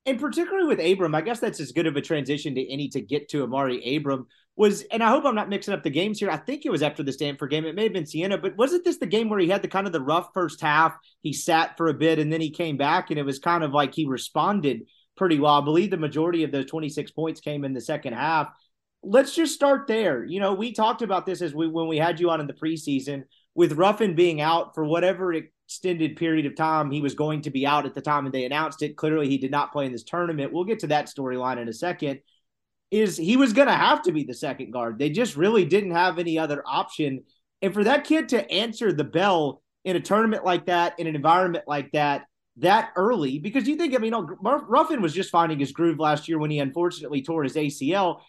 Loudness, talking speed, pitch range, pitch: -24 LUFS, 255 wpm, 145-195 Hz, 165 Hz